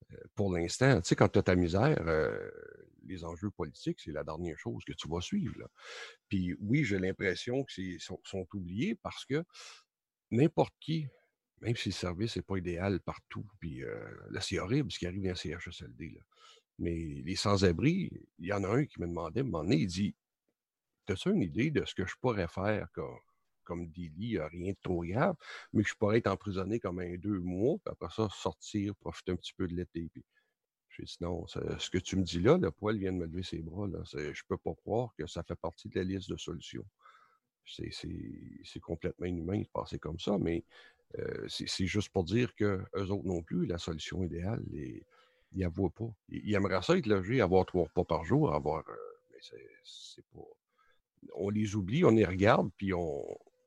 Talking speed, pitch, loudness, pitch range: 215 wpm, 95 Hz, -34 LUFS, 90-115 Hz